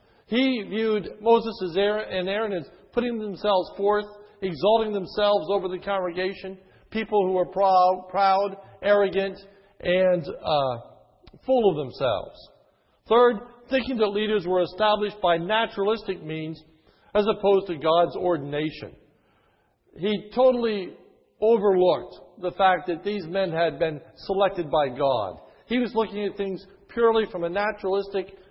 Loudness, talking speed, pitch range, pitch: -24 LUFS, 130 wpm, 180-215 Hz, 195 Hz